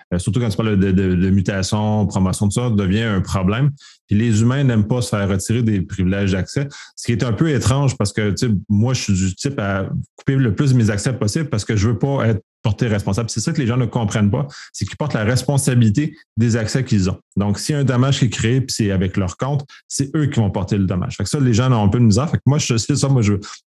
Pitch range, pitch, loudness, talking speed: 100-130 Hz, 115 Hz, -18 LUFS, 285 wpm